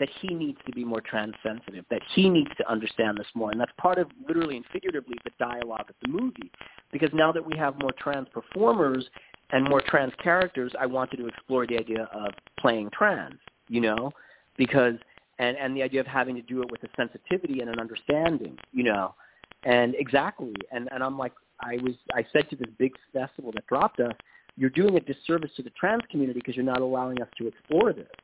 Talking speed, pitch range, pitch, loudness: 215 wpm, 120-145 Hz, 130 Hz, -27 LUFS